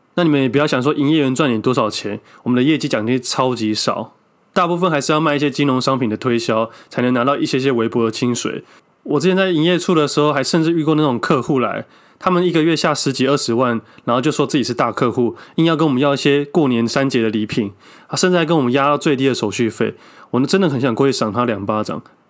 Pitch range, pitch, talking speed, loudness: 120-155 Hz, 135 Hz, 370 characters per minute, -17 LUFS